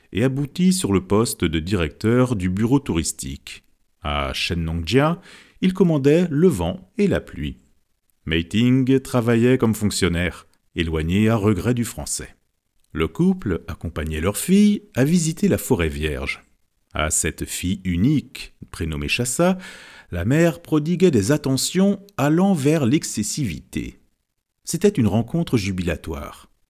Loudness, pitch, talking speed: -21 LUFS, 110 Hz, 125 wpm